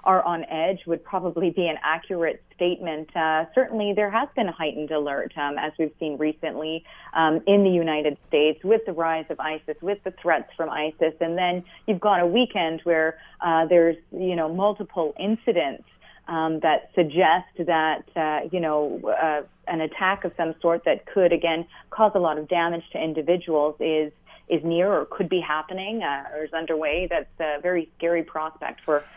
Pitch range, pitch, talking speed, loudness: 155-180 Hz, 165 Hz, 185 wpm, -24 LUFS